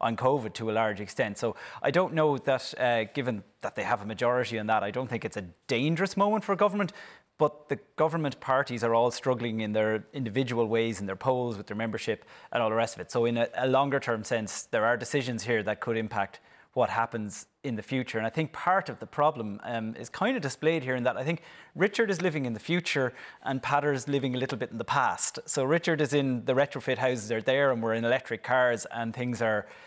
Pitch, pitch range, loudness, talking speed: 125 Hz, 115-140 Hz, -29 LUFS, 245 wpm